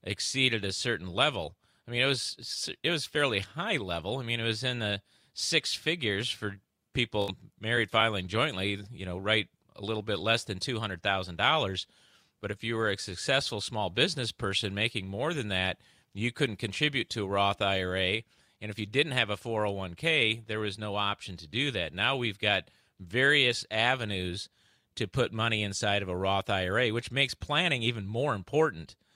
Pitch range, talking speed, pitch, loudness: 100-120 Hz, 180 wpm, 110 Hz, -29 LUFS